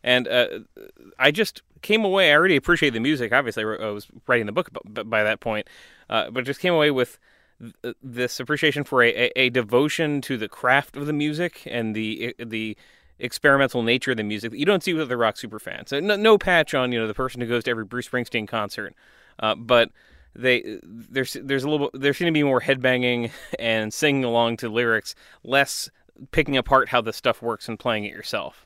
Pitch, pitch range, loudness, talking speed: 125 Hz, 115-140 Hz, -22 LUFS, 210 wpm